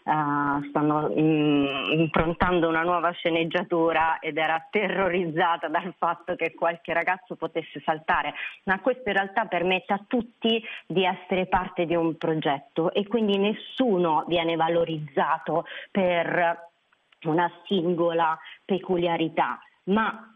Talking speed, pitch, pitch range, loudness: 120 wpm, 170 Hz, 160-185 Hz, -25 LUFS